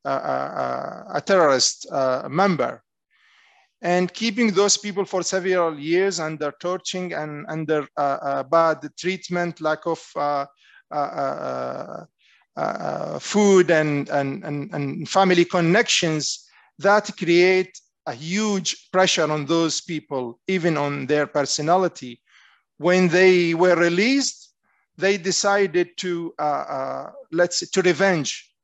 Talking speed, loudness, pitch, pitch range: 125 wpm, -21 LUFS, 175 Hz, 150-190 Hz